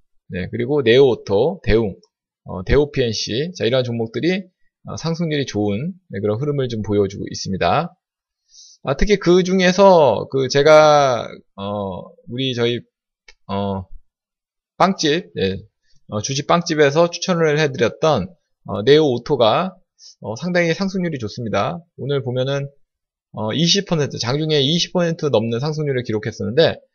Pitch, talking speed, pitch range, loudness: 140 Hz, 260 characters per minute, 110-170 Hz, -18 LUFS